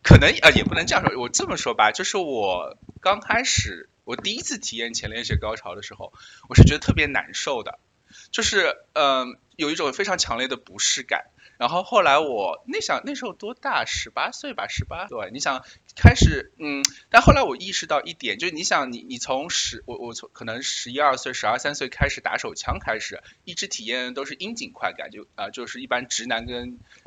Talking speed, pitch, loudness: 310 characters per minute, 150 Hz, -22 LUFS